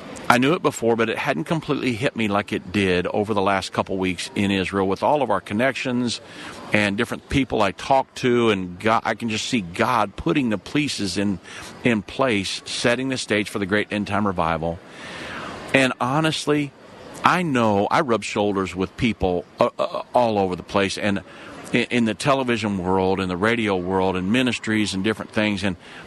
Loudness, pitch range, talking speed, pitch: -22 LUFS, 95-120 Hz, 195 wpm, 105 Hz